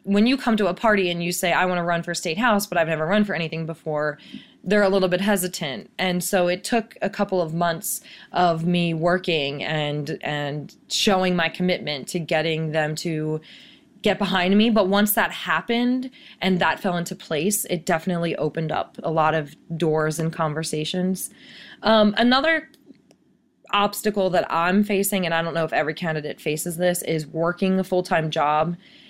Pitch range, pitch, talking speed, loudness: 160-205 Hz, 180 Hz, 185 wpm, -22 LUFS